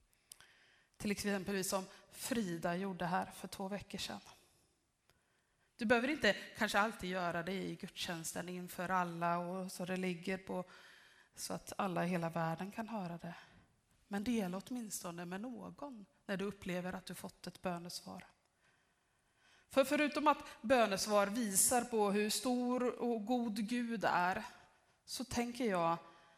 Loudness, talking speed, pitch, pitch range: -38 LUFS, 145 wpm, 195 Hz, 180-230 Hz